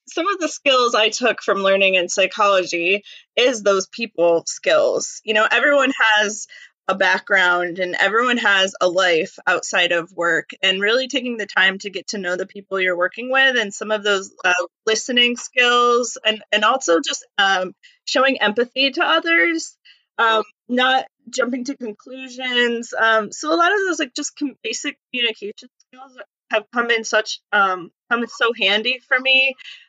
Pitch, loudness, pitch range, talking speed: 225 Hz, -18 LUFS, 195-260 Hz, 170 wpm